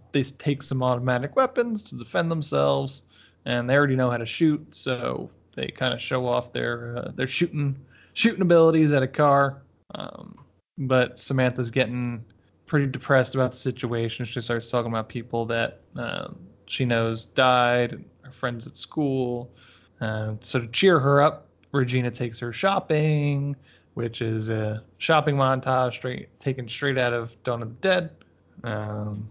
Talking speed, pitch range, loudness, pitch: 160 wpm, 115-140 Hz, -25 LUFS, 125 Hz